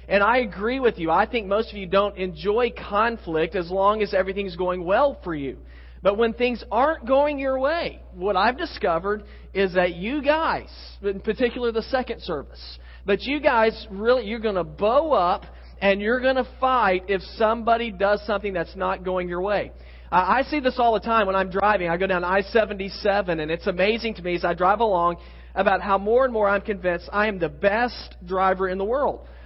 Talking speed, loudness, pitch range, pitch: 210 wpm, -23 LUFS, 185-235 Hz, 200 Hz